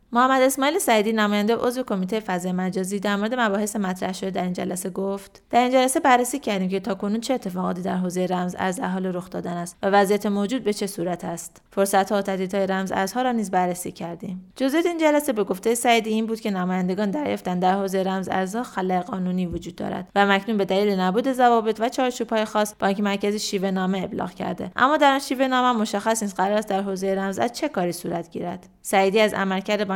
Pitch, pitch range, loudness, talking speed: 200 Hz, 185-225 Hz, -23 LUFS, 210 wpm